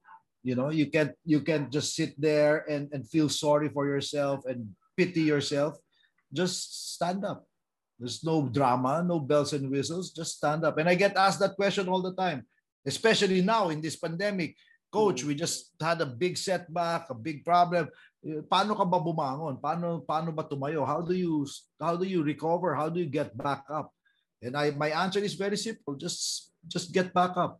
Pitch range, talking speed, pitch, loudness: 145-180 Hz, 185 wpm, 160 Hz, -29 LUFS